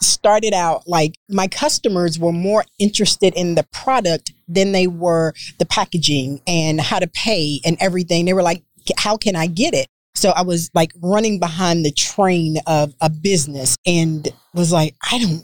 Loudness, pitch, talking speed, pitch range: -17 LUFS, 175 Hz, 180 wpm, 160-195 Hz